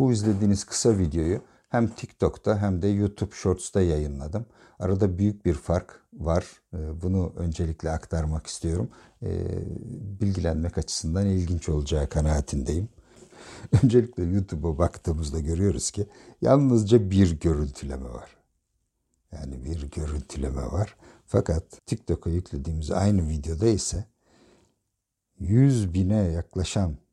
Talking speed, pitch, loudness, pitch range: 105 wpm, 90 Hz, -26 LUFS, 80-105 Hz